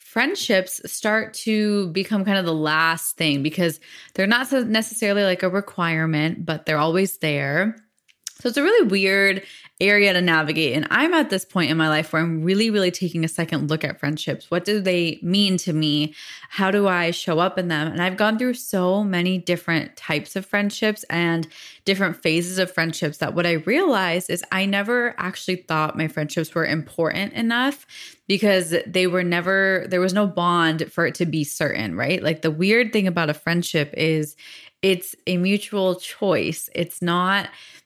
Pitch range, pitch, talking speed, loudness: 160-200 Hz, 180 Hz, 185 wpm, -21 LUFS